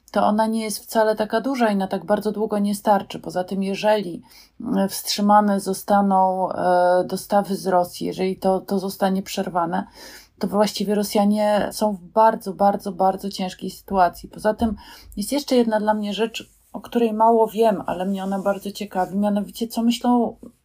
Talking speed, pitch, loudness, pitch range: 165 wpm, 205 Hz, -21 LUFS, 190-220 Hz